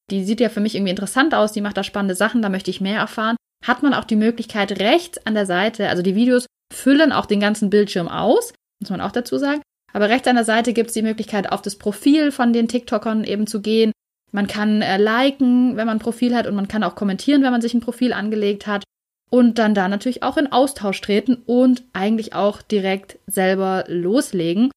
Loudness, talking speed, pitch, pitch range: -19 LUFS, 225 wpm, 220 Hz, 200-245 Hz